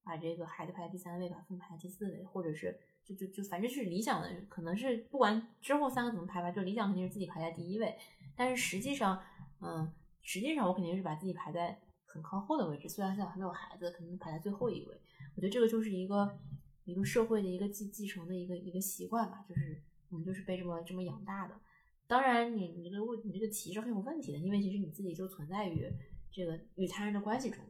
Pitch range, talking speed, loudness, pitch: 175-215 Hz, 380 characters per minute, -38 LUFS, 190 Hz